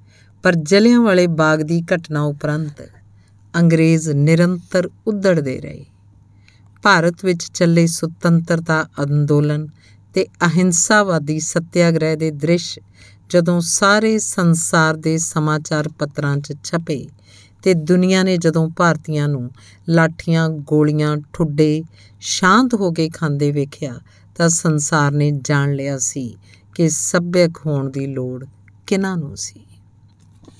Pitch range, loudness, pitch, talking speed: 135-170 Hz, -17 LUFS, 155 Hz, 110 wpm